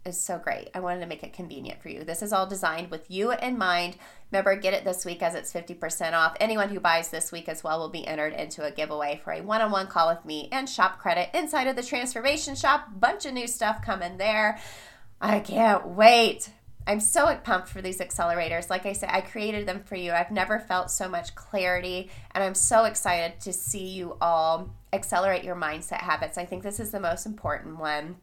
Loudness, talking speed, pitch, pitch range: -26 LUFS, 225 wpm, 185 Hz, 170-210 Hz